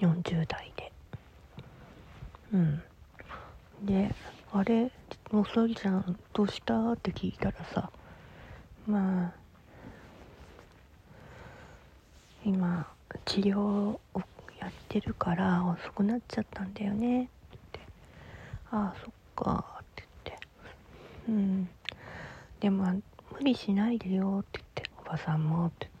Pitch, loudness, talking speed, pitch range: 195 Hz, -32 LUFS, 210 characters per minute, 175-210 Hz